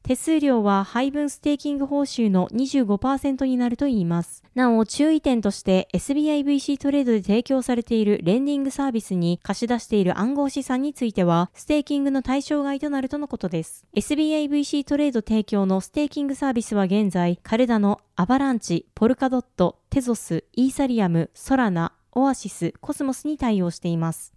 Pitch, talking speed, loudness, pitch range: 245 Hz, 400 characters per minute, -23 LUFS, 200-280 Hz